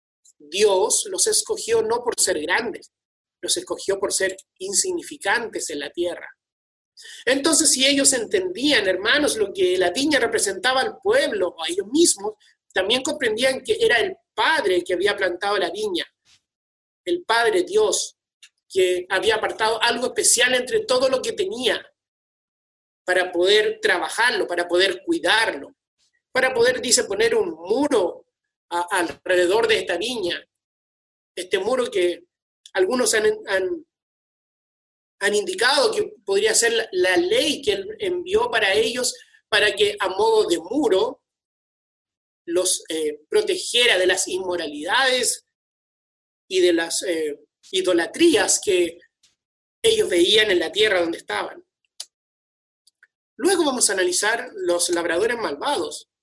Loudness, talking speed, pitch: -20 LUFS, 130 wpm, 360 Hz